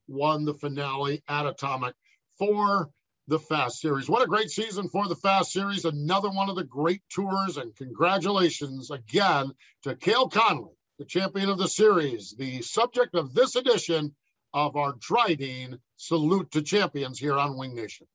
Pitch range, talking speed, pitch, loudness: 140-195 Hz, 160 wpm, 155 Hz, -26 LUFS